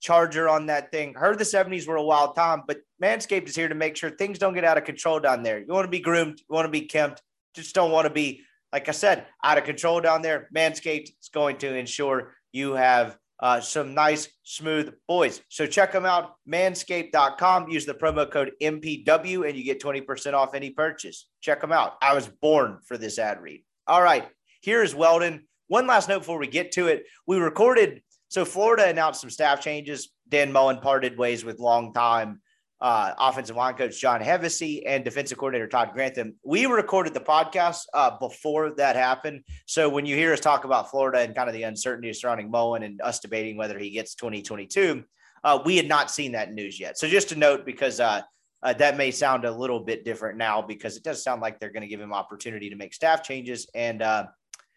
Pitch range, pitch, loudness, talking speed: 125-160 Hz, 145 Hz, -24 LUFS, 215 wpm